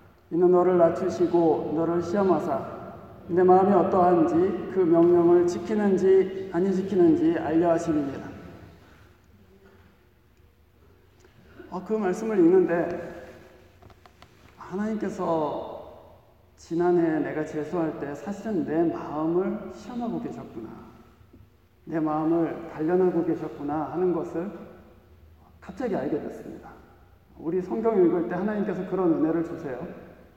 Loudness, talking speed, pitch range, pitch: -24 LUFS, 245 characters per minute, 115-185 Hz, 165 Hz